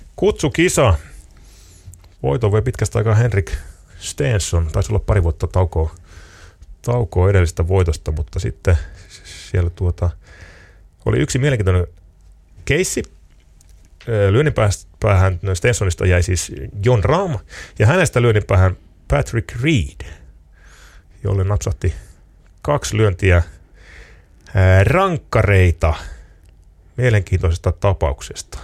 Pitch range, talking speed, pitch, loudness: 85-105 Hz, 85 wpm, 95 Hz, -18 LUFS